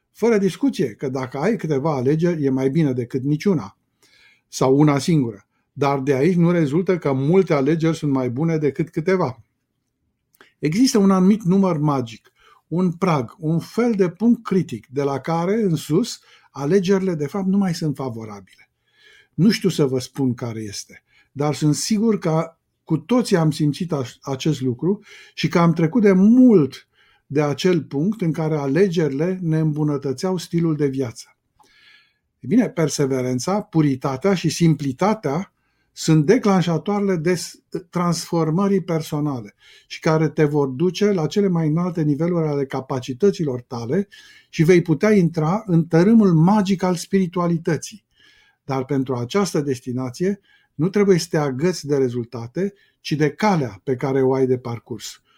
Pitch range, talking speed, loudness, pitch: 140-190 Hz, 150 wpm, -20 LUFS, 160 Hz